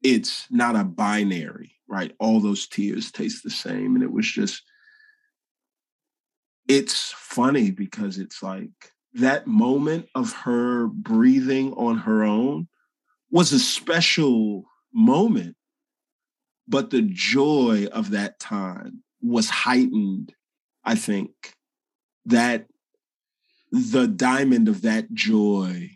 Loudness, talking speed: -22 LUFS, 110 wpm